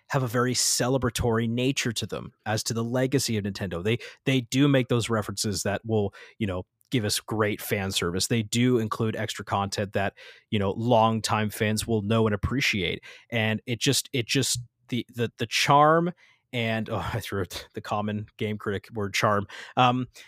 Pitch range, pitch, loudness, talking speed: 105-125 Hz, 115 Hz, -26 LUFS, 185 wpm